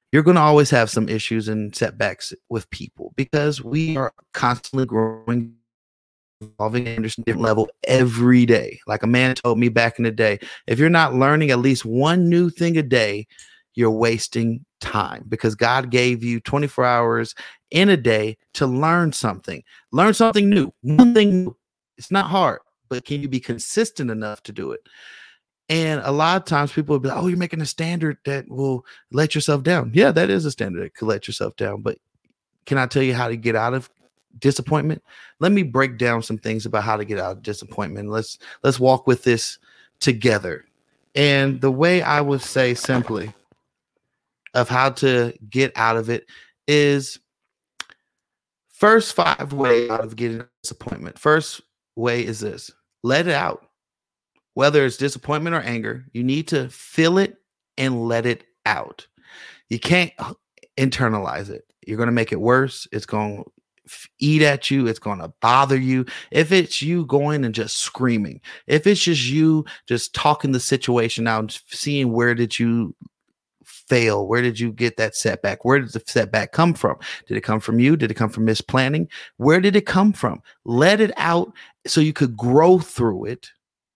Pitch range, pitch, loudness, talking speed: 115-150 Hz, 130 Hz, -20 LUFS, 185 wpm